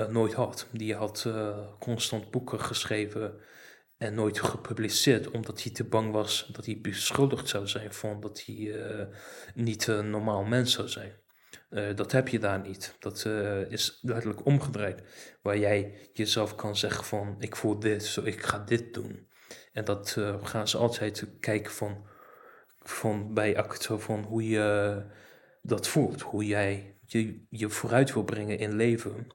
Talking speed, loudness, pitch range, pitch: 165 wpm, -30 LUFS, 105-115 Hz, 105 Hz